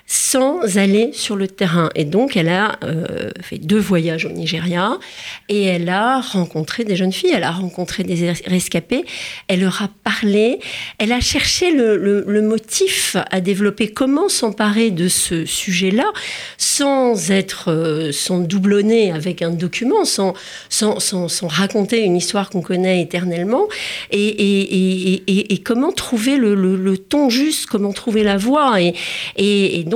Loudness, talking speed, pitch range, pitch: -17 LUFS, 170 wpm, 180-230 Hz, 200 Hz